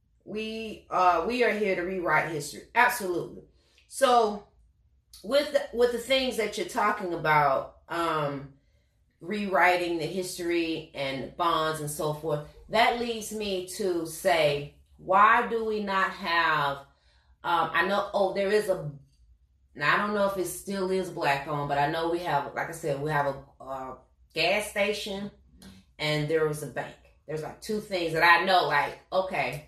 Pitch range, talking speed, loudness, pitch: 145-200 Hz, 170 wpm, -27 LUFS, 170 Hz